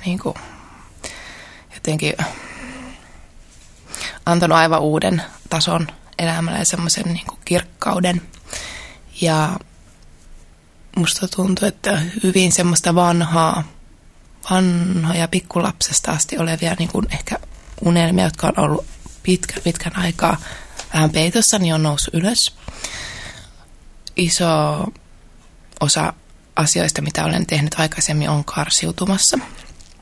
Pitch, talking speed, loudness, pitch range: 170 Hz, 95 wpm, -18 LUFS, 160-185 Hz